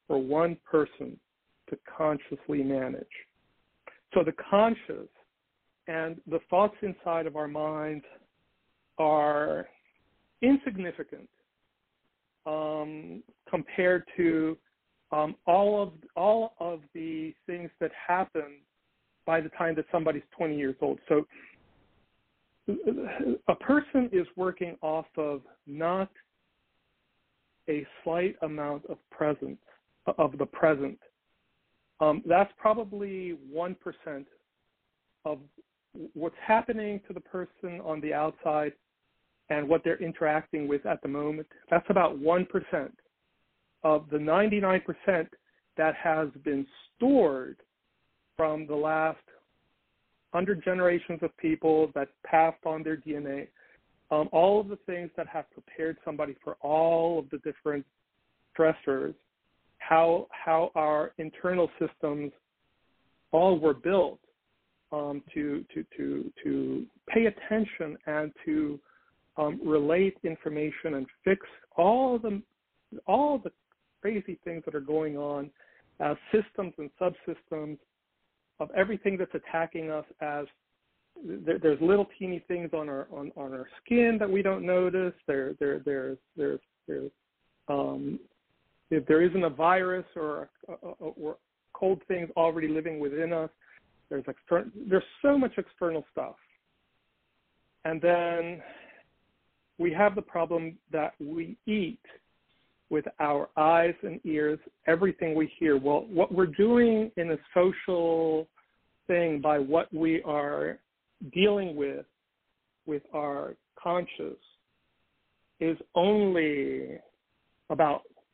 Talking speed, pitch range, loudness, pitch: 120 wpm, 150-180 Hz, -29 LUFS, 160 Hz